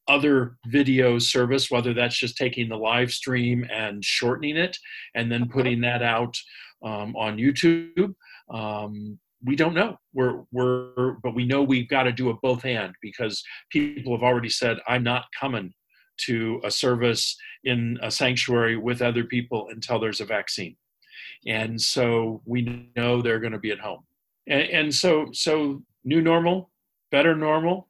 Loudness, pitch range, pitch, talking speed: -24 LUFS, 115-135 Hz, 125 Hz, 165 wpm